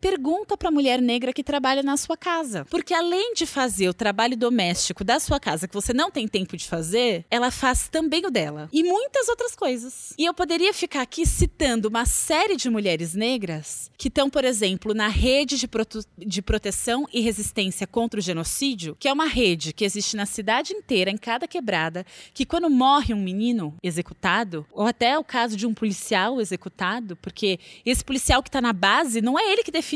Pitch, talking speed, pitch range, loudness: 240 Hz, 195 wpm, 200-290 Hz, -23 LUFS